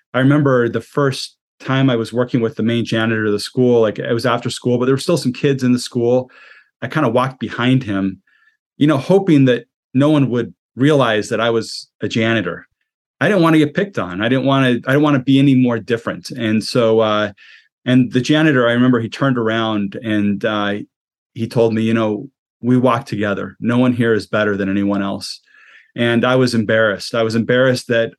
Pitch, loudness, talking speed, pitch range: 120 Hz, -16 LUFS, 220 wpm, 110-130 Hz